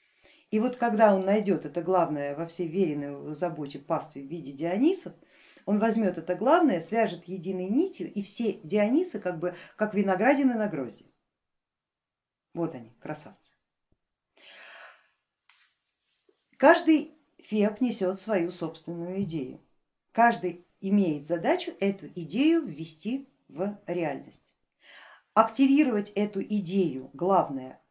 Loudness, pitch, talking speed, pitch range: -27 LUFS, 195 Hz, 110 wpm, 170-230 Hz